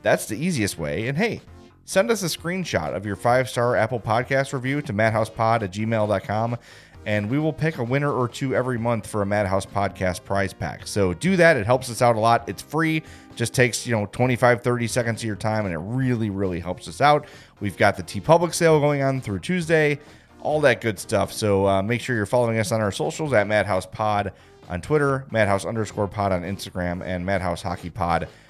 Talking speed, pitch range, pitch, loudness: 210 wpm, 100-130 Hz, 110 Hz, -23 LUFS